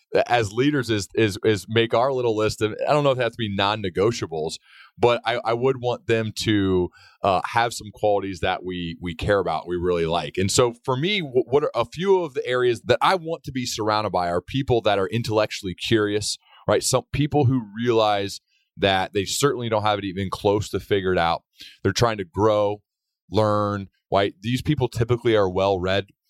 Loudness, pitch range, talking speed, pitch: -23 LUFS, 100-120 Hz, 205 wpm, 110 Hz